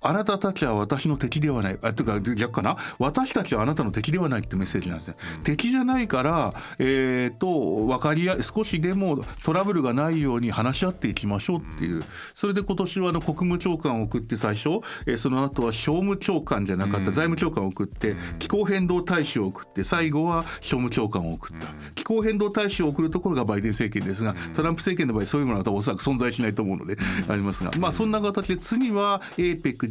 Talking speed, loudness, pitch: 445 characters per minute, -25 LUFS, 145 Hz